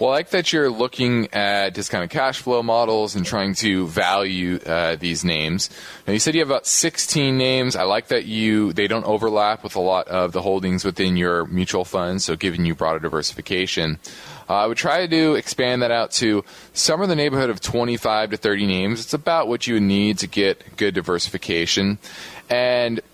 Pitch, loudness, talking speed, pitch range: 105 Hz, -20 LUFS, 205 wpm, 95-120 Hz